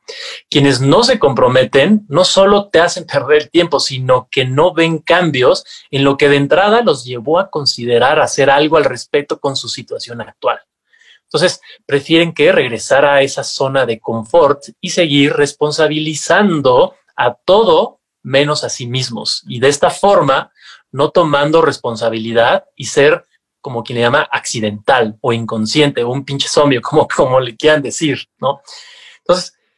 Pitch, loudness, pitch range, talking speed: 145 Hz, -13 LUFS, 130-175 Hz, 155 wpm